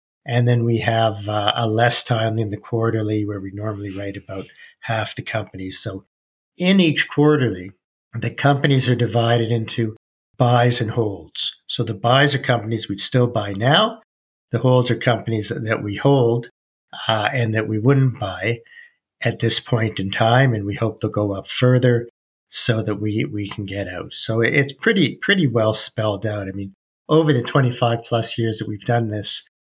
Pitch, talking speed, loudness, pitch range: 115 Hz, 180 wpm, -20 LUFS, 105-120 Hz